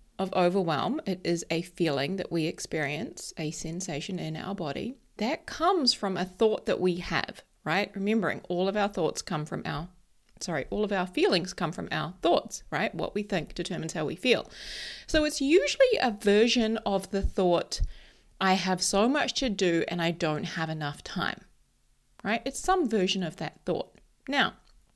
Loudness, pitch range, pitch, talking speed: -29 LUFS, 170-215 Hz, 185 Hz, 185 wpm